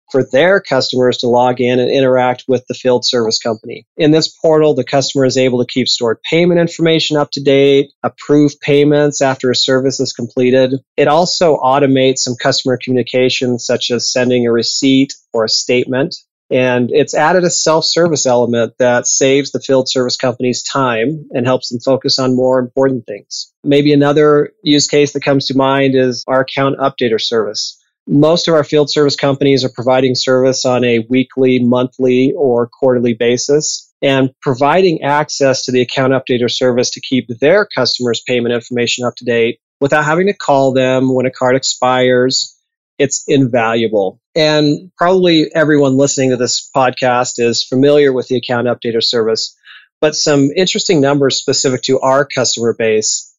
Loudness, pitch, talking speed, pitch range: -12 LUFS, 130 Hz, 170 wpm, 125-145 Hz